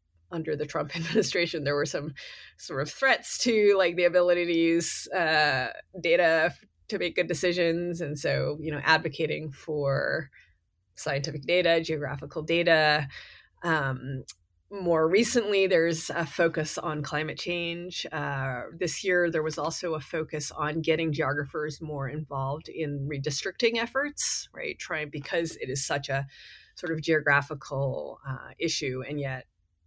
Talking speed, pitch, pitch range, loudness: 145 wpm, 155 Hz, 145-170 Hz, -27 LUFS